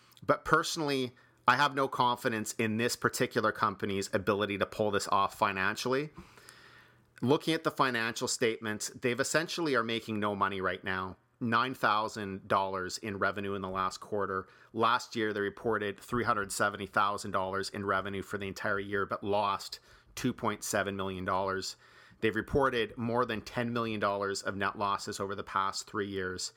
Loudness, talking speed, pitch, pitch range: -32 LUFS, 145 wpm, 105 Hz, 100-120 Hz